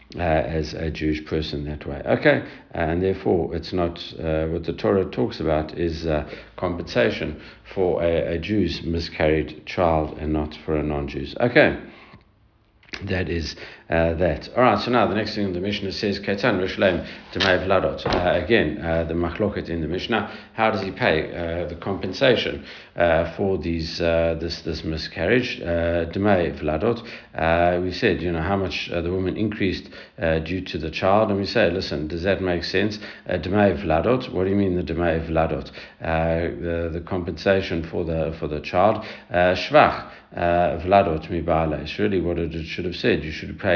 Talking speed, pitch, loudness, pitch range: 165 wpm, 85 Hz, -23 LUFS, 80-95 Hz